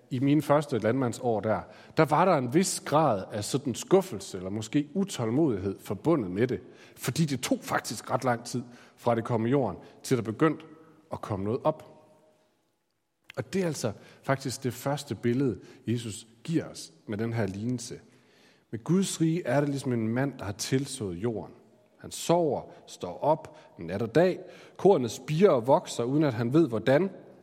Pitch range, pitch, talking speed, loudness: 115-155 Hz, 130 Hz, 180 wpm, -28 LUFS